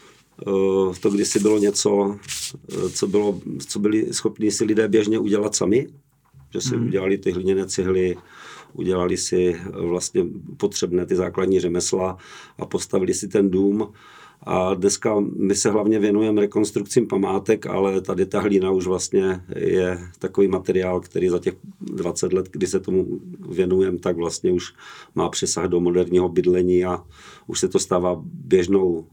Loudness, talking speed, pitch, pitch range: -21 LUFS, 150 wpm, 95 Hz, 90-105 Hz